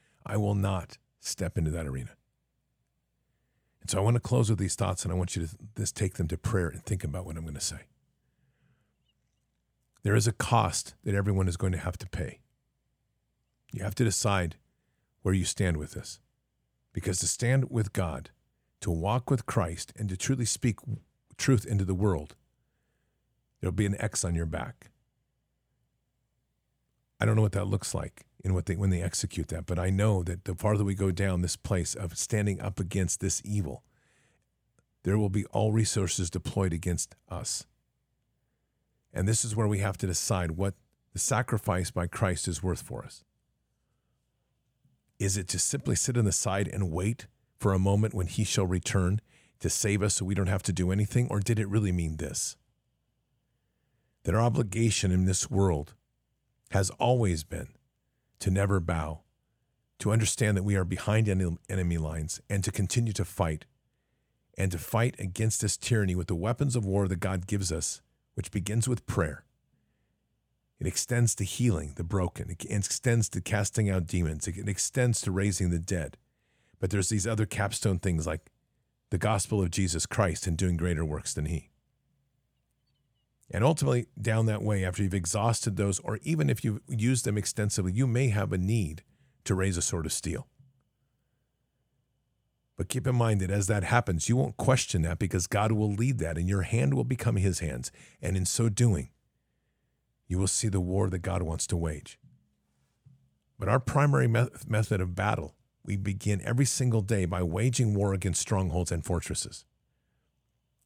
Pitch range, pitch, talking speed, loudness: 90-115 Hz, 100 Hz, 180 wpm, -29 LUFS